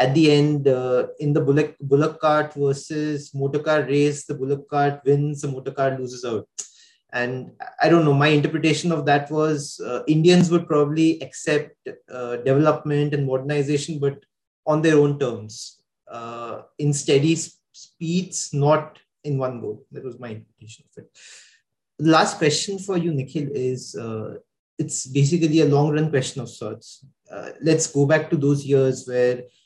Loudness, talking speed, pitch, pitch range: -21 LUFS, 165 wpm, 145 Hz, 135-155 Hz